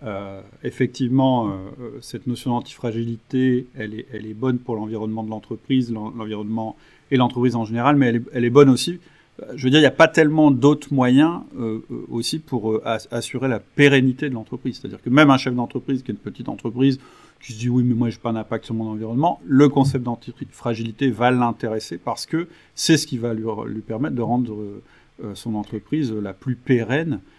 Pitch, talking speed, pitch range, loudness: 120 Hz, 200 wpm, 115-135 Hz, -20 LUFS